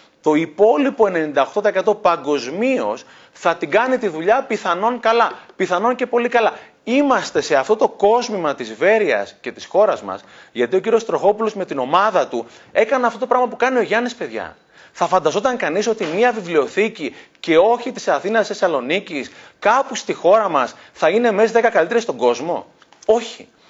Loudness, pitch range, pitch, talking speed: -18 LUFS, 190-240 Hz, 220 Hz, 165 wpm